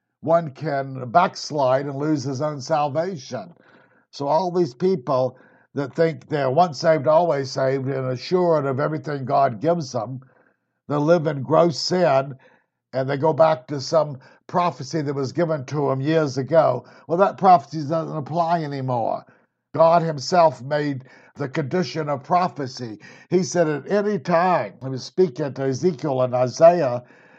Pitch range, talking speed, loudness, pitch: 135-165 Hz, 155 wpm, -21 LUFS, 150 Hz